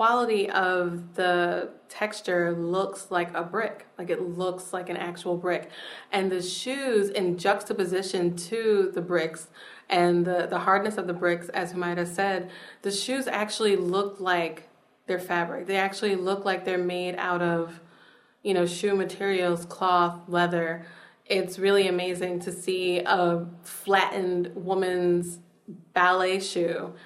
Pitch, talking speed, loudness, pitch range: 180 Hz, 140 wpm, -27 LUFS, 175-195 Hz